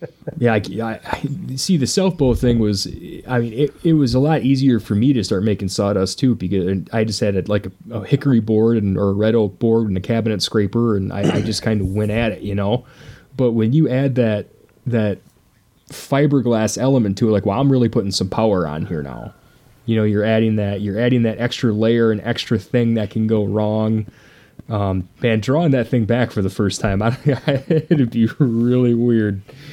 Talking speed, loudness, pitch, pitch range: 215 wpm, -18 LUFS, 115 Hz, 105-125 Hz